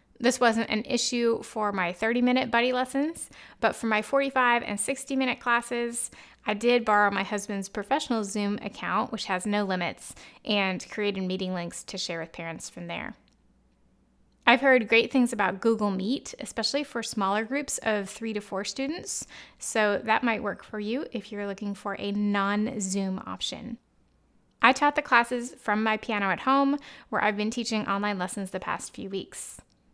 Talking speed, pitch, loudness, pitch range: 180 wpm, 220 Hz, -27 LUFS, 205-245 Hz